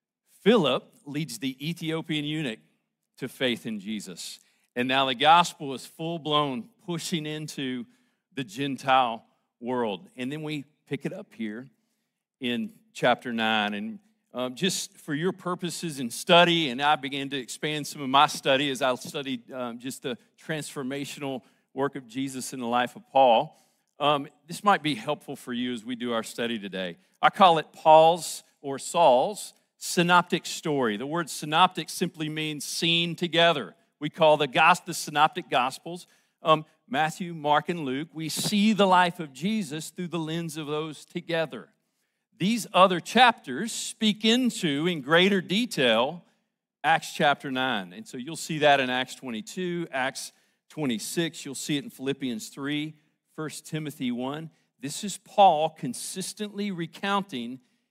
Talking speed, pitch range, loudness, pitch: 155 wpm, 140-190 Hz, -26 LUFS, 160 Hz